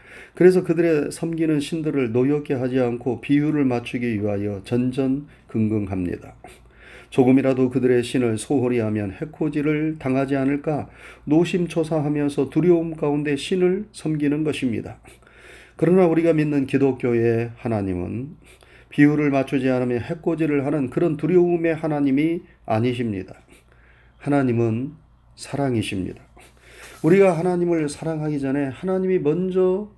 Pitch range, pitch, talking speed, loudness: 125-160 Hz, 145 Hz, 315 characters per minute, -21 LUFS